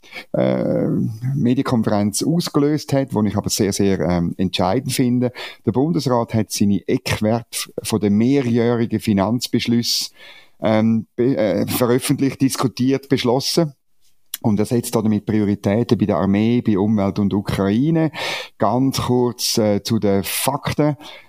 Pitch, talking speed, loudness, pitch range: 115 Hz, 125 wpm, -19 LUFS, 105-130 Hz